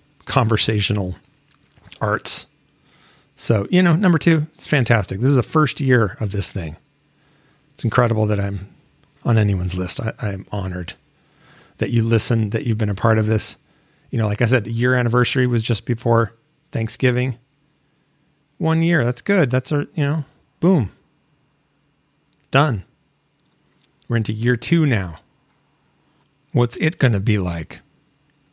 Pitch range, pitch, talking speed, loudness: 110-150 Hz, 130 Hz, 145 wpm, -19 LUFS